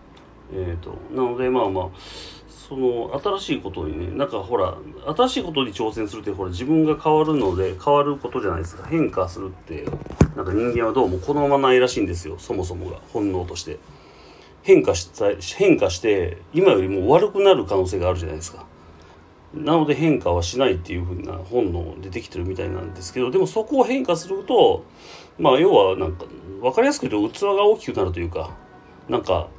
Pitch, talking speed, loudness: 120 Hz, 400 characters per minute, -21 LUFS